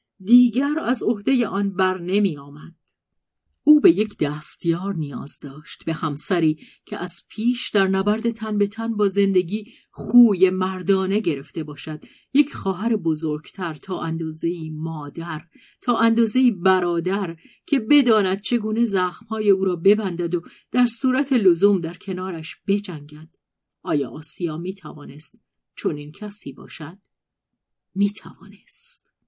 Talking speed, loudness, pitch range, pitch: 125 wpm, -22 LUFS, 165-220 Hz, 190 Hz